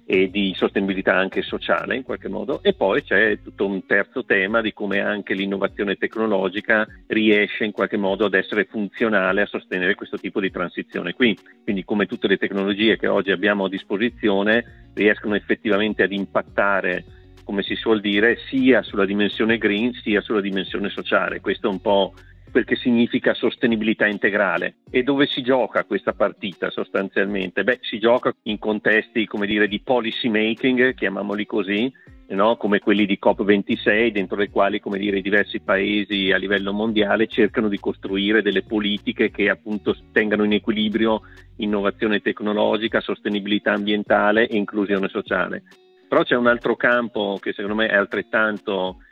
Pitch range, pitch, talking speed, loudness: 100-110 Hz, 105 Hz, 160 wpm, -21 LUFS